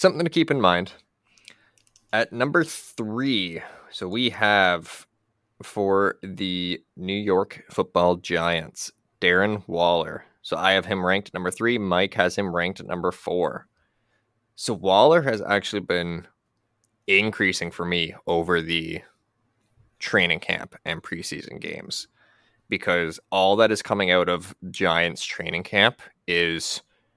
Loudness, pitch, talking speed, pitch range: -23 LUFS, 95 Hz, 130 wpm, 90-110 Hz